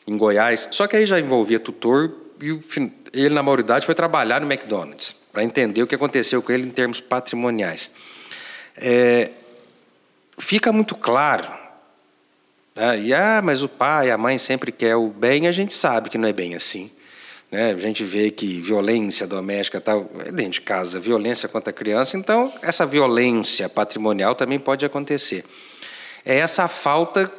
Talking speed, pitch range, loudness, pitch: 165 wpm, 105-150 Hz, -20 LUFS, 125 Hz